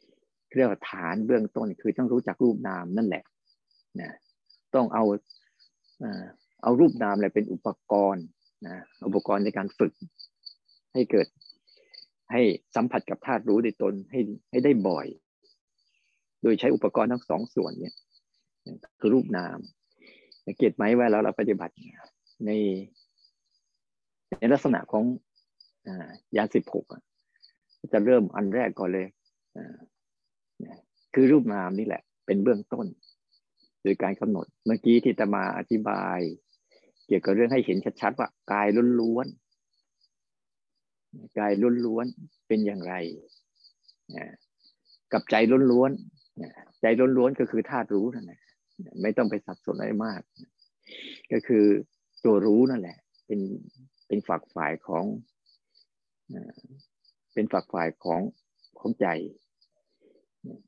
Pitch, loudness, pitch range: 110 Hz, -26 LUFS, 100-125 Hz